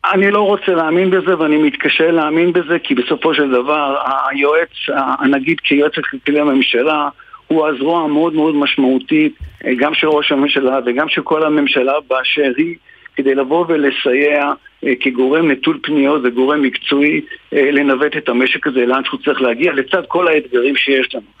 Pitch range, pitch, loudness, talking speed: 140-165 Hz, 150 Hz, -14 LUFS, 155 wpm